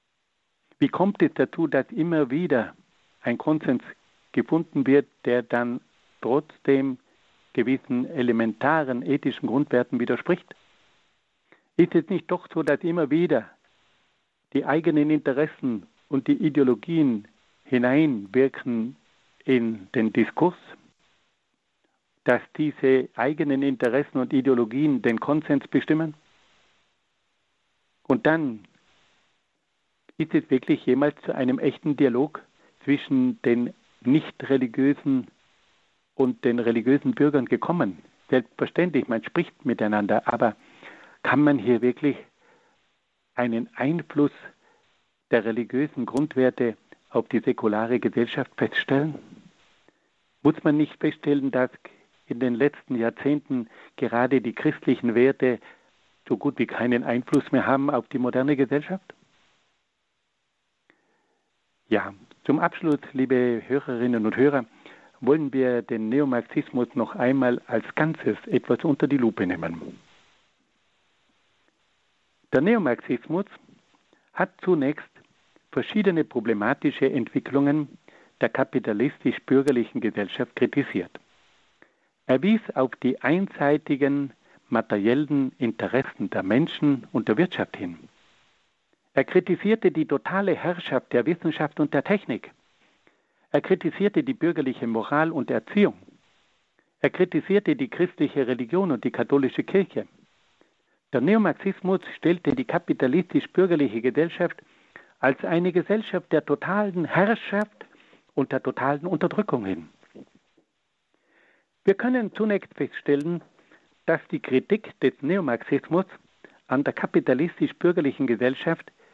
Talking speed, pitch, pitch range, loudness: 105 wpm, 140 Hz, 125-165 Hz, -24 LUFS